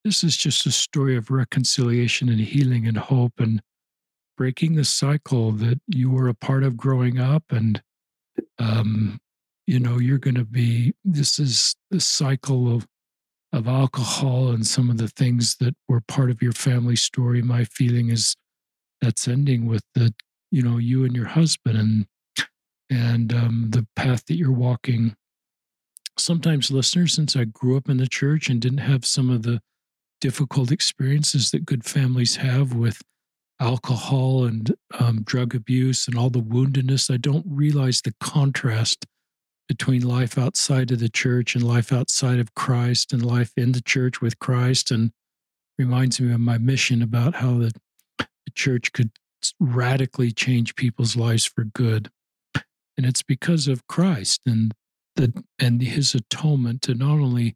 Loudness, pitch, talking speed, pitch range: -21 LUFS, 125 Hz, 165 wpm, 120-135 Hz